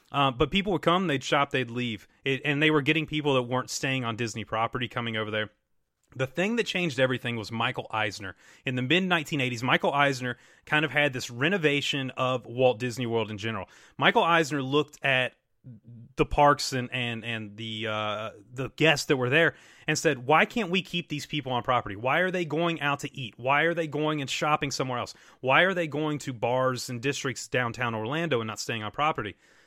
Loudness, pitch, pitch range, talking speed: -27 LUFS, 130 Hz, 120-150 Hz, 210 wpm